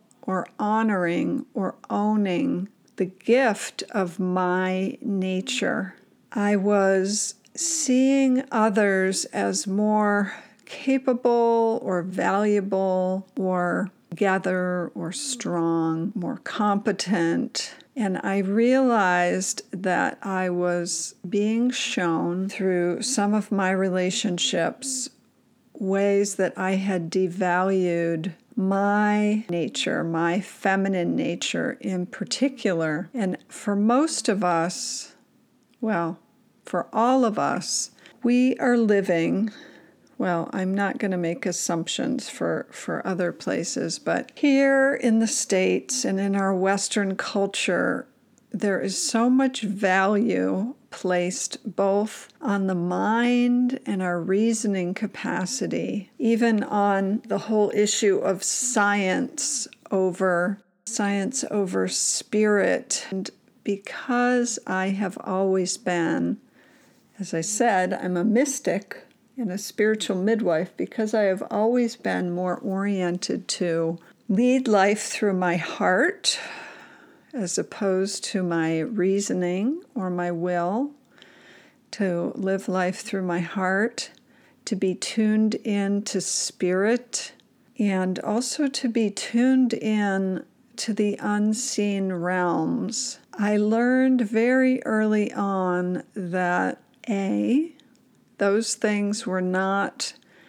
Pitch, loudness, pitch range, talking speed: 205 Hz, -24 LUFS, 185-235 Hz, 105 wpm